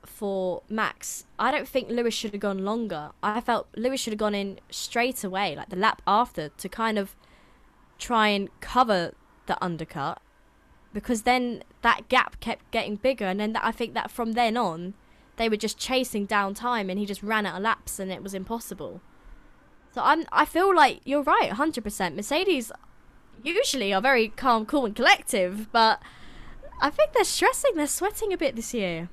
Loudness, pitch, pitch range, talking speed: -25 LUFS, 225 Hz, 200-260 Hz, 185 wpm